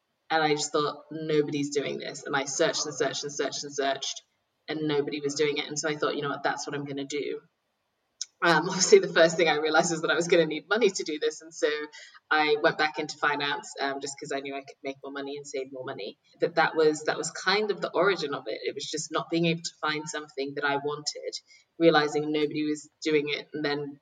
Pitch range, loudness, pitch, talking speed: 145-155 Hz, -27 LUFS, 150 Hz, 255 wpm